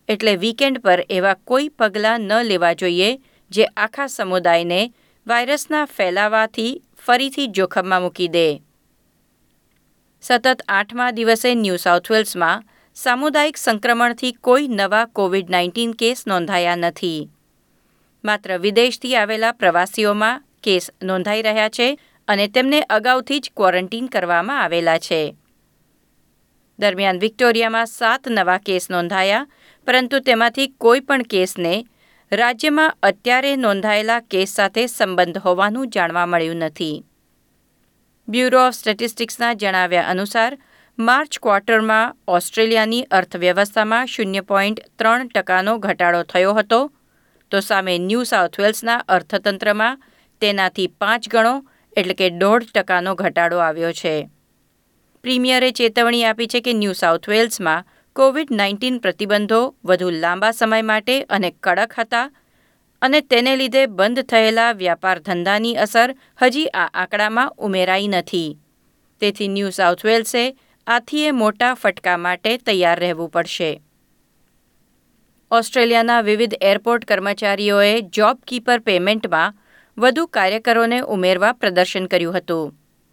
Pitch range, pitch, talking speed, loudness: 185-240 Hz, 215 Hz, 110 wpm, -17 LUFS